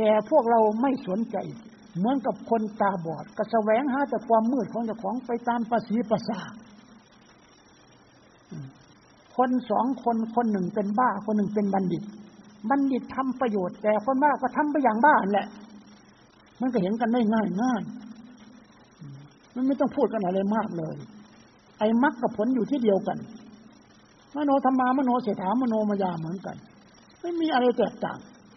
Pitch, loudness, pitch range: 225 Hz, -26 LUFS, 210-250 Hz